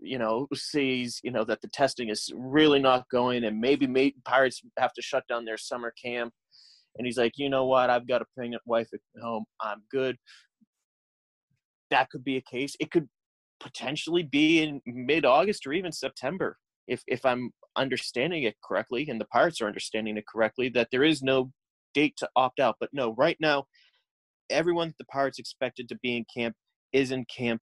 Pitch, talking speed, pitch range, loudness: 130 Hz, 195 wpm, 120-140 Hz, -28 LUFS